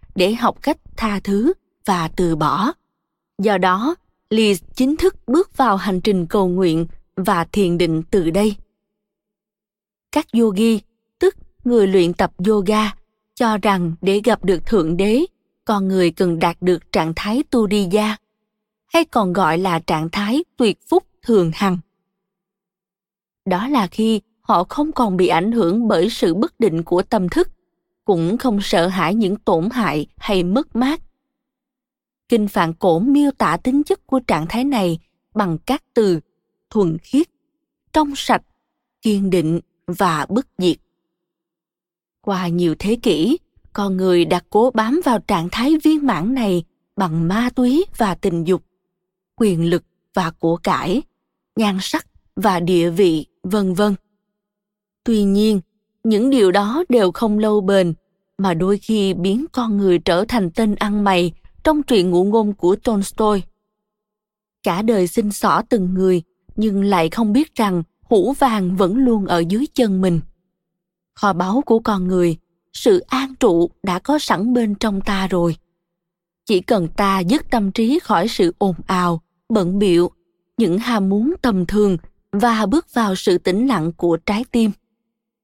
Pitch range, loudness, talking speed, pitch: 180-230 Hz, -18 LUFS, 160 wpm, 205 Hz